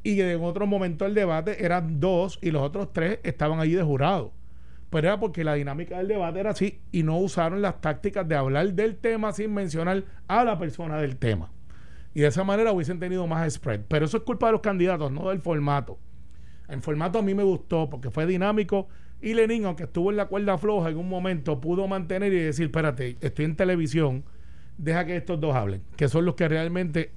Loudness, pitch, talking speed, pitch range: -26 LUFS, 175 Hz, 215 wpm, 150-195 Hz